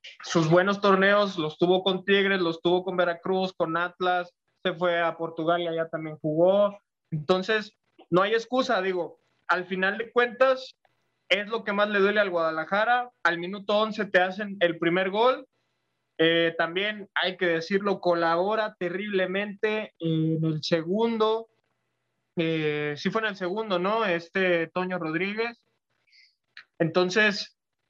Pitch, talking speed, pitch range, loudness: 185 Hz, 145 wpm, 170-210 Hz, -25 LUFS